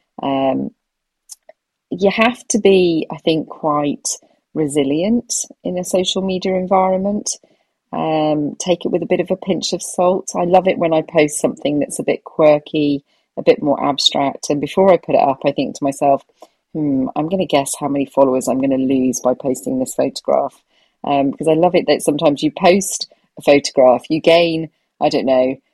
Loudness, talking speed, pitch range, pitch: -16 LUFS, 190 wpm, 145-185 Hz, 160 Hz